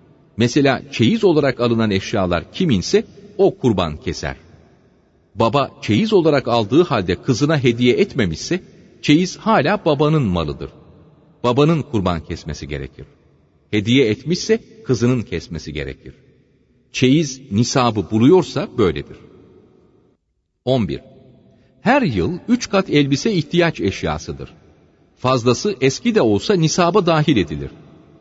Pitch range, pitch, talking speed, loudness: 100-160 Hz, 135 Hz, 105 wpm, -18 LUFS